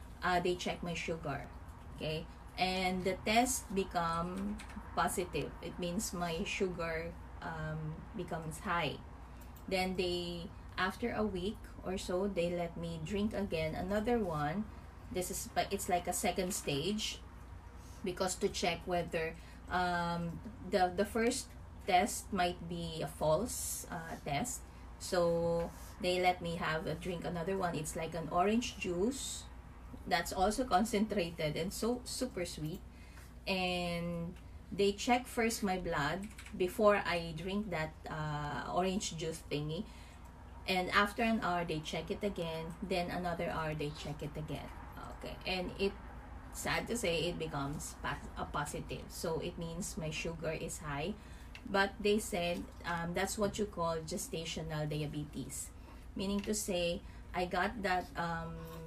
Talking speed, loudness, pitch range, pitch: 140 wpm, -37 LUFS, 160-195 Hz, 175 Hz